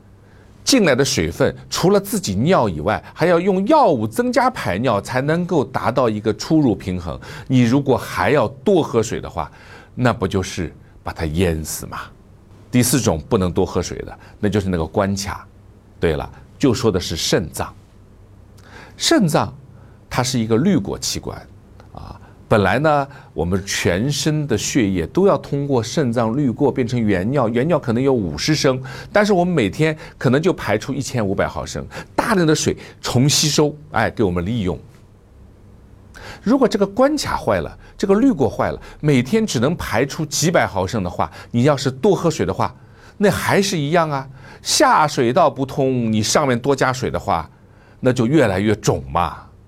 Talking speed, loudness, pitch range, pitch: 250 characters per minute, -18 LUFS, 100-150 Hz, 120 Hz